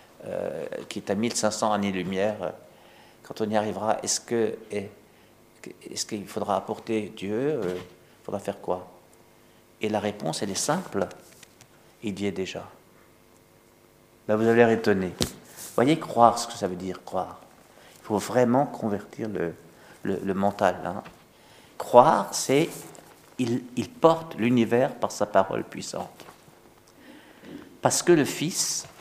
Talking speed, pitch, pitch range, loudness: 140 wpm, 105 Hz, 90-115 Hz, -26 LUFS